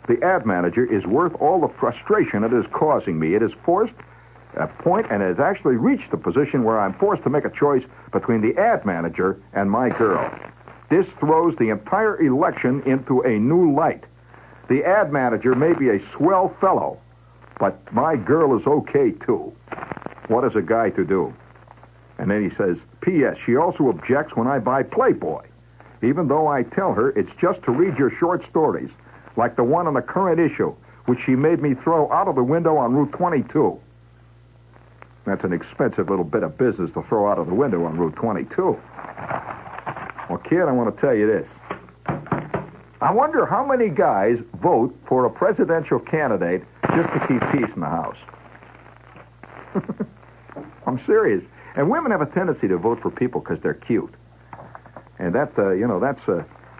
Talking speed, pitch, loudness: 185 wpm, 125 Hz, -21 LUFS